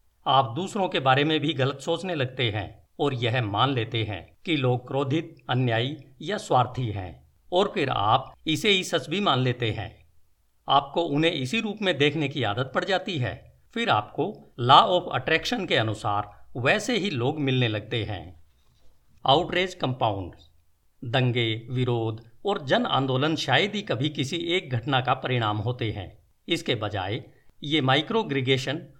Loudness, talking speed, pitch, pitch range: -25 LUFS, 160 wpm, 130 Hz, 110-155 Hz